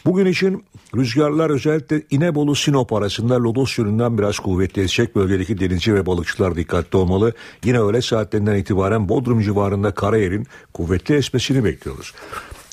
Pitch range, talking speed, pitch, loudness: 100-135 Hz, 125 wpm, 110 Hz, -19 LUFS